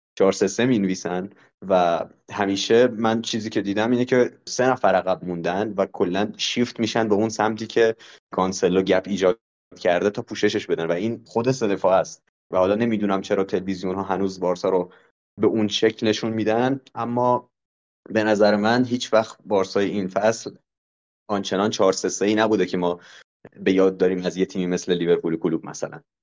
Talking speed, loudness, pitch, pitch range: 180 wpm, -22 LUFS, 105 Hz, 95-115 Hz